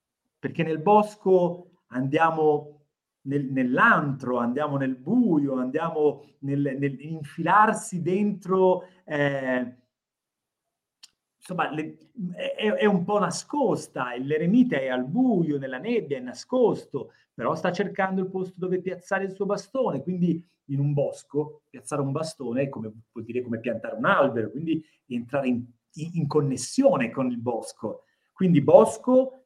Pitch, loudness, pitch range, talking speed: 155 Hz, -25 LUFS, 135-190 Hz, 130 wpm